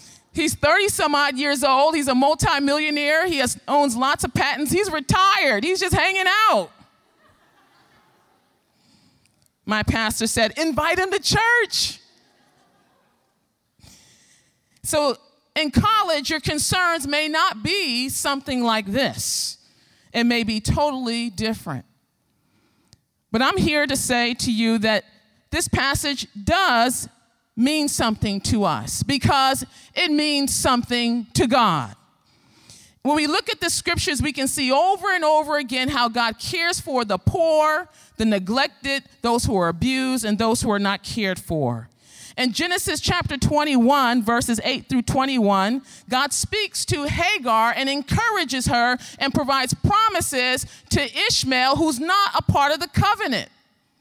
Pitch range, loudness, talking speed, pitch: 235-310 Hz, -20 LUFS, 140 wpm, 275 Hz